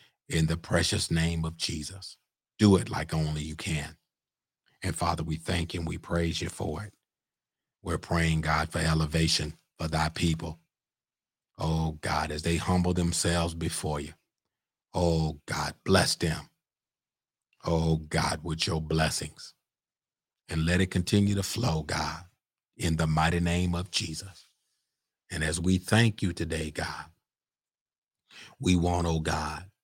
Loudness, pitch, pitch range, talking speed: -29 LUFS, 85 Hz, 80-90 Hz, 145 wpm